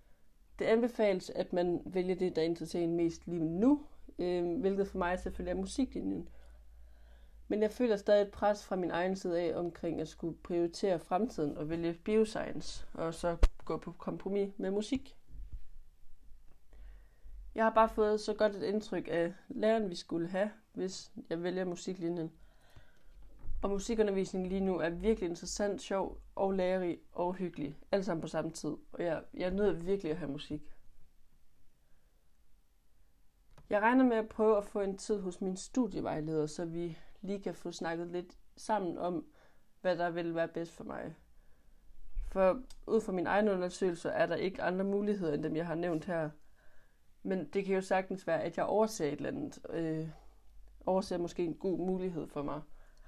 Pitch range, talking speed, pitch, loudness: 160-200 Hz, 175 wpm, 180 Hz, -35 LUFS